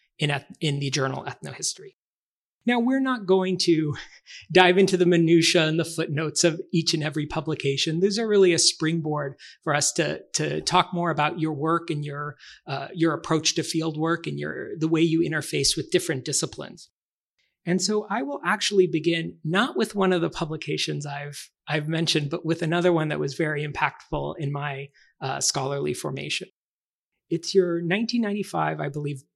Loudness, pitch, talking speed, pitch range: -24 LUFS, 165 Hz, 175 wpm, 150-180 Hz